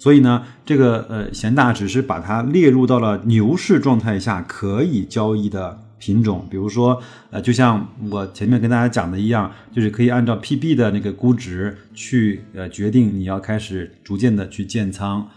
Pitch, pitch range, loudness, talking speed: 110 Hz, 100-120 Hz, -18 LUFS, 275 characters per minute